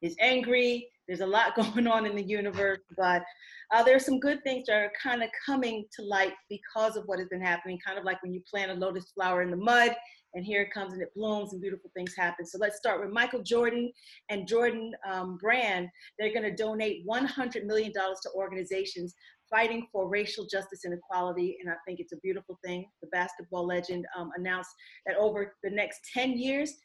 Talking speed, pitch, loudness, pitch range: 210 wpm, 200 Hz, -30 LUFS, 185-230 Hz